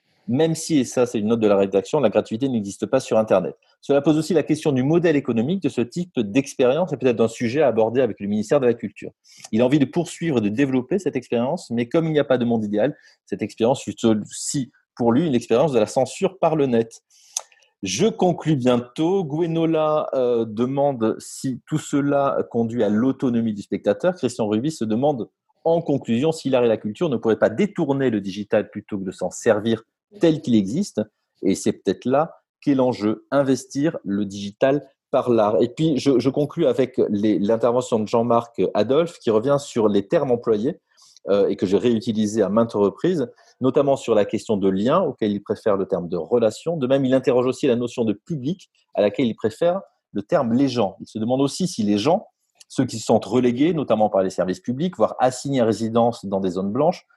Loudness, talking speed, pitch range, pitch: -21 LUFS, 210 wpm, 110-145 Hz, 125 Hz